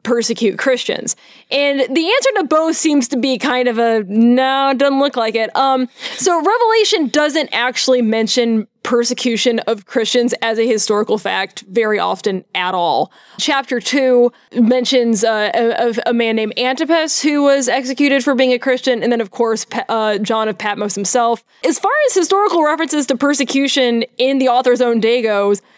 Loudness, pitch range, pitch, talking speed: -15 LUFS, 230-275 Hz, 250 Hz, 170 wpm